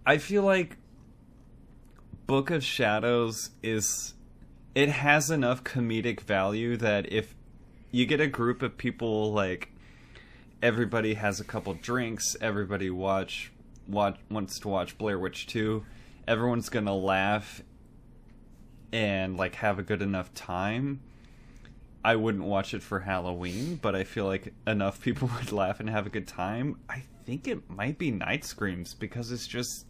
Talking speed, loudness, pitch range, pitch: 150 wpm, -30 LUFS, 100-125 Hz, 115 Hz